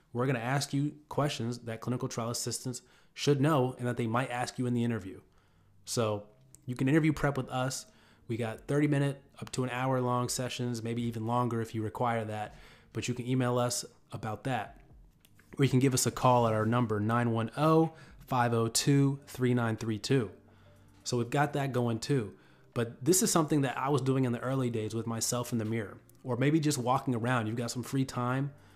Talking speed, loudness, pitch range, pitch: 205 wpm, -31 LUFS, 115-135 Hz, 125 Hz